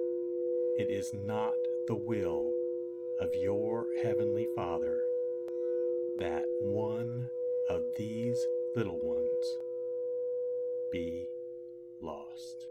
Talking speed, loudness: 80 wpm, -34 LUFS